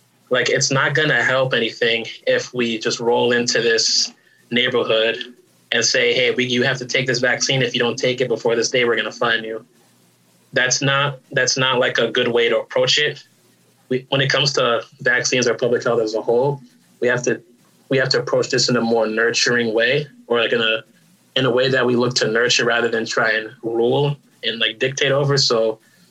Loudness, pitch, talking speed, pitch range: -18 LUFS, 125 Hz, 215 wpm, 115-140 Hz